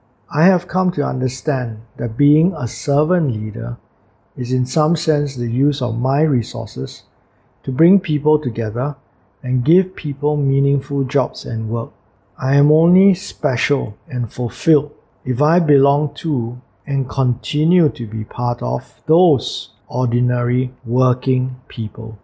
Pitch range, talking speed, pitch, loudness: 120-150 Hz, 135 wpm, 130 Hz, -18 LUFS